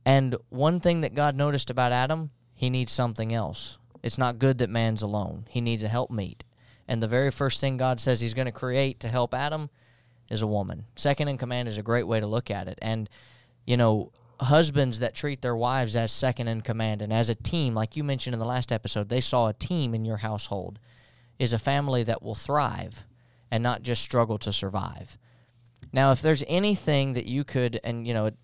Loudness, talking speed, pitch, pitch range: -27 LUFS, 215 wpm, 120 Hz, 115-130 Hz